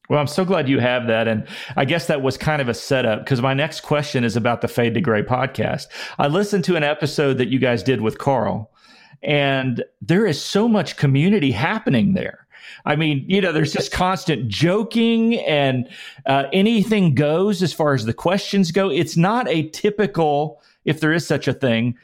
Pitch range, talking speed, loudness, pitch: 130-185 Hz, 200 wpm, -19 LUFS, 150 Hz